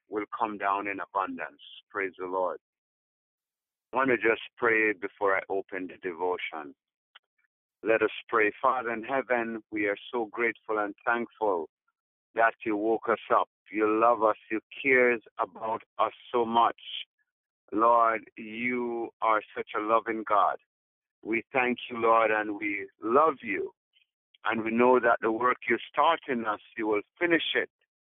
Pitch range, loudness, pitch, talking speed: 105-125 Hz, -28 LUFS, 115 Hz, 155 wpm